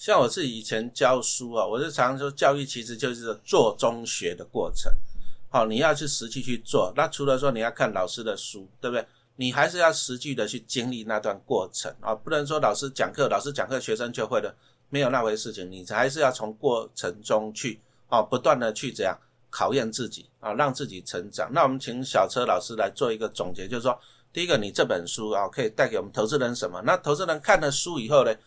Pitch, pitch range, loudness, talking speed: 125 Hz, 115-145 Hz, -26 LUFS, 325 characters per minute